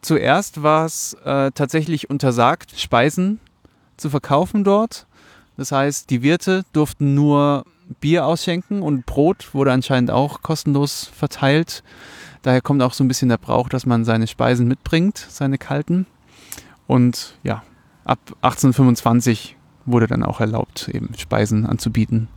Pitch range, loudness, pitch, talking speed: 125-155 Hz, -19 LUFS, 135 Hz, 135 wpm